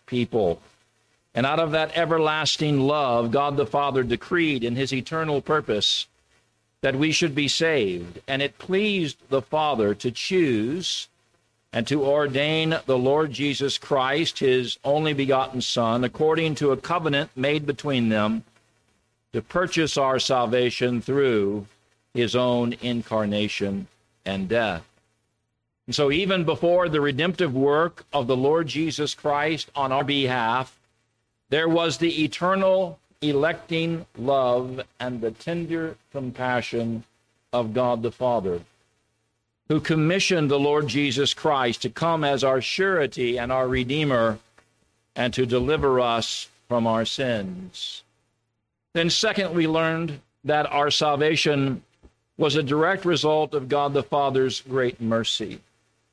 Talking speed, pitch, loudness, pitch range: 130 wpm, 135 Hz, -23 LUFS, 115-155 Hz